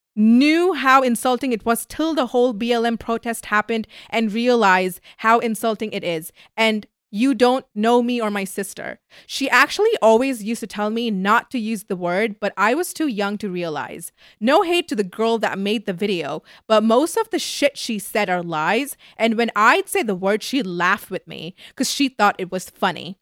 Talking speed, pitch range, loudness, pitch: 200 wpm, 200-250 Hz, -20 LUFS, 225 Hz